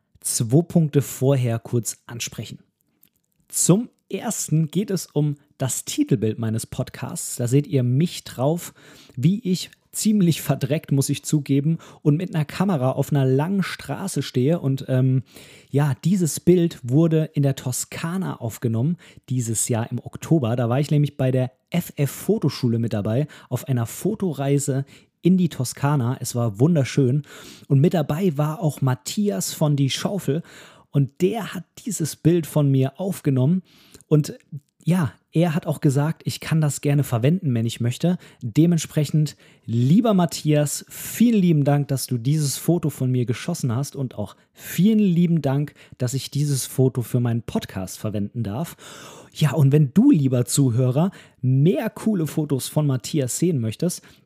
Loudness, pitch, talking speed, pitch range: -22 LUFS, 145 Hz, 155 wpm, 130-165 Hz